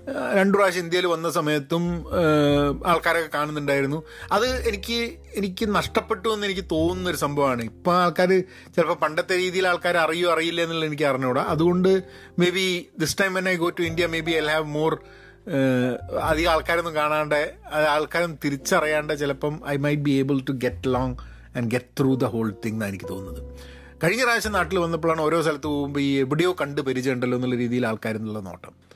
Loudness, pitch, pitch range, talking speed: -23 LUFS, 155 Hz, 140-175 Hz, 165 wpm